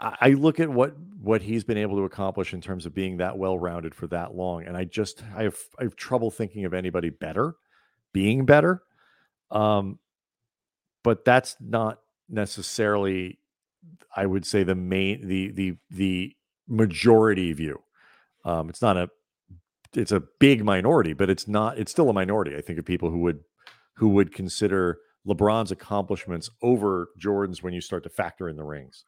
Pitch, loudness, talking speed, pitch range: 100 Hz, -25 LUFS, 175 wpm, 90-110 Hz